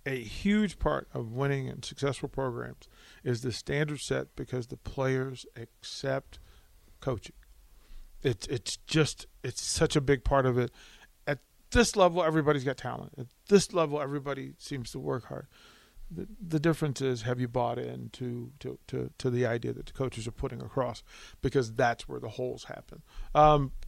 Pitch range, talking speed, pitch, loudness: 115-145 Hz, 170 wpm, 130 Hz, -31 LUFS